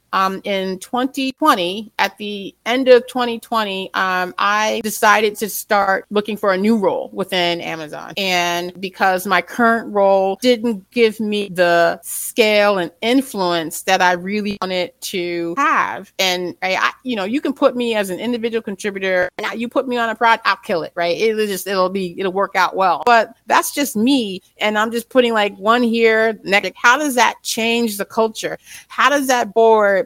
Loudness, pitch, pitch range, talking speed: -17 LUFS, 210 Hz, 190-235 Hz, 185 wpm